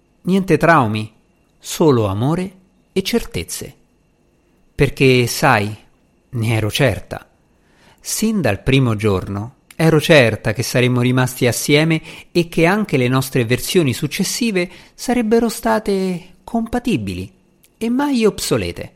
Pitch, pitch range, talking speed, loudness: 150 Hz, 125-190 Hz, 110 wpm, -17 LUFS